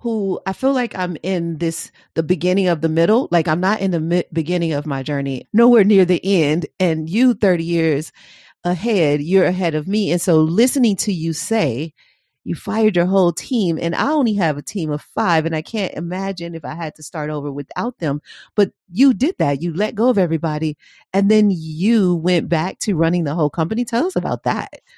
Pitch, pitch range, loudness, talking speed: 175 Hz, 160-210 Hz, -18 LUFS, 215 wpm